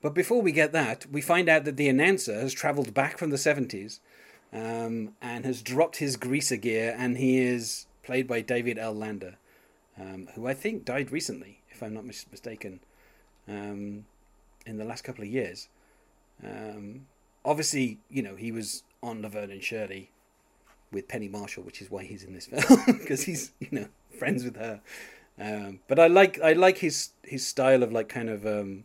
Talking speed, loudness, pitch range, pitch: 185 wpm, -27 LUFS, 105-140 Hz, 120 Hz